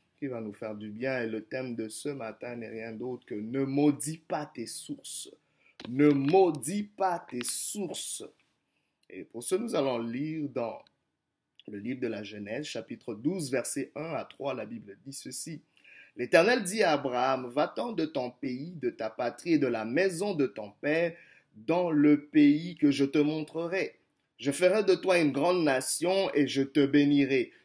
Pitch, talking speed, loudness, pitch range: 145 Hz, 180 wpm, -29 LUFS, 125-170 Hz